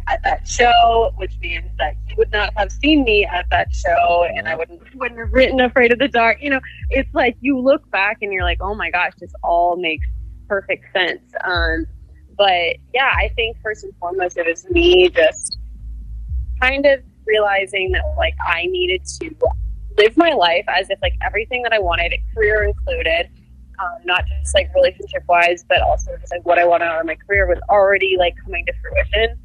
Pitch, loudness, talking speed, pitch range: 210 Hz, -17 LUFS, 200 wpm, 175-270 Hz